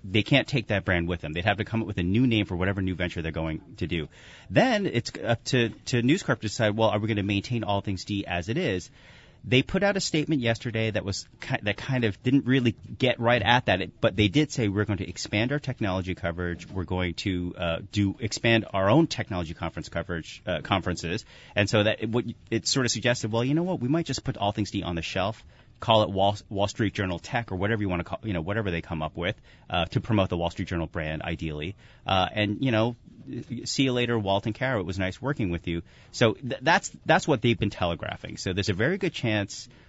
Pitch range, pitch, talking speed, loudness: 95-120 Hz, 105 Hz, 250 wpm, -27 LUFS